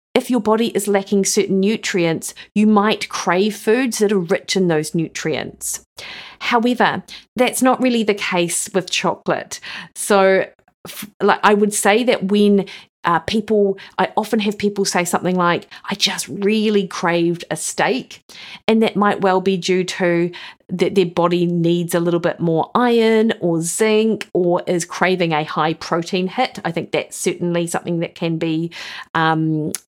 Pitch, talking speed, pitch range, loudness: 195 Hz, 160 wpm, 175-210 Hz, -18 LUFS